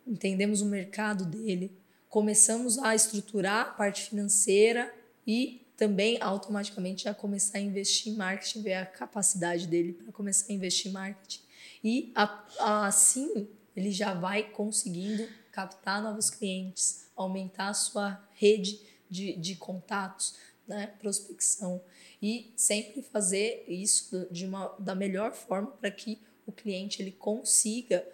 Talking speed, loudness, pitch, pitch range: 135 wpm, -29 LUFS, 205 Hz, 190-215 Hz